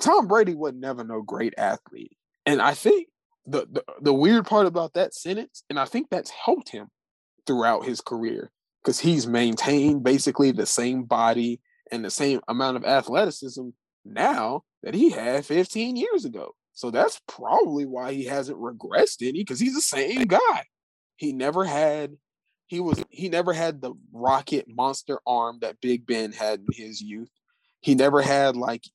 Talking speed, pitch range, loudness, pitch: 170 wpm, 125-190 Hz, -24 LUFS, 140 Hz